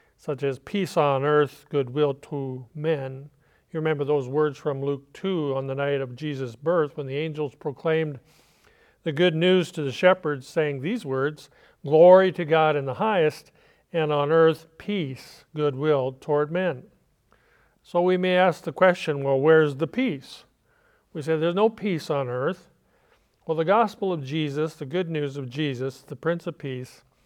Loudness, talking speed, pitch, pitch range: -24 LUFS, 170 wpm, 150 Hz, 140-170 Hz